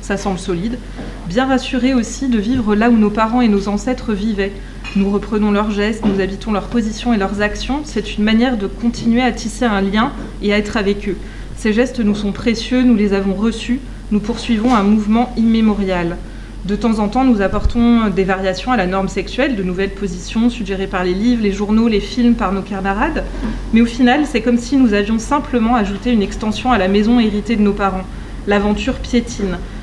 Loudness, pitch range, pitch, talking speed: -16 LUFS, 200-240 Hz, 220 Hz, 205 wpm